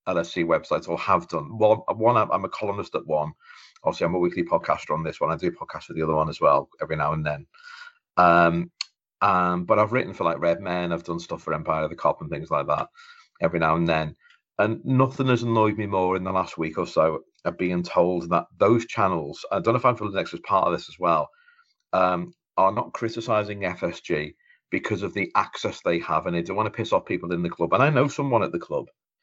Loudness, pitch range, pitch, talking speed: -24 LUFS, 85-115 Hz, 90 Hz, 240 wpm